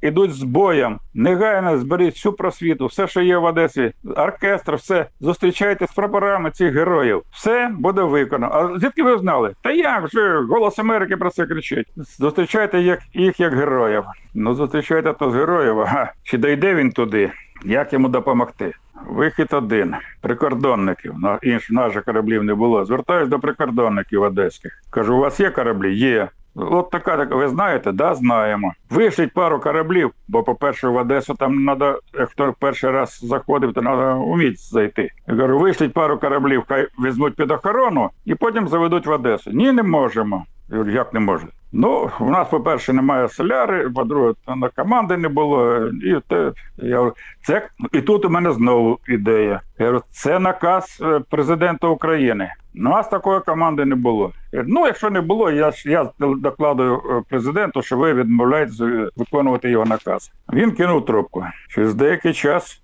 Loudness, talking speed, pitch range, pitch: -18 LUFS, 160 wpm, 125-180 Hz, 150 Hz